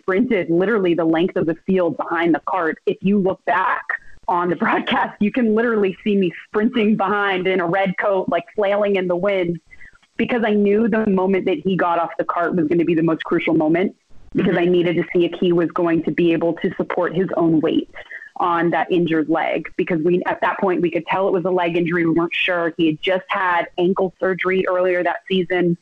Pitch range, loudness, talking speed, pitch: 170-195 Hz, -19 LUFS, 230 wpm, 185 Hz